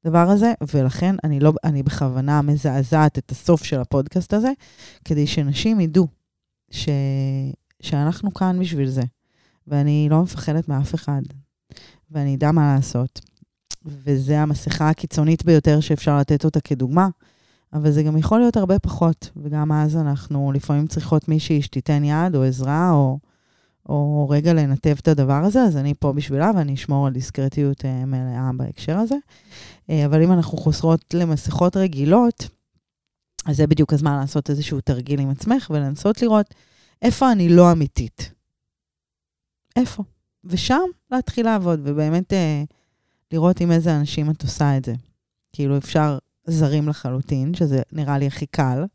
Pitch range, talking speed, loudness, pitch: 140-165 Hz, 145 wpm, -20 LUFS, 150 Hz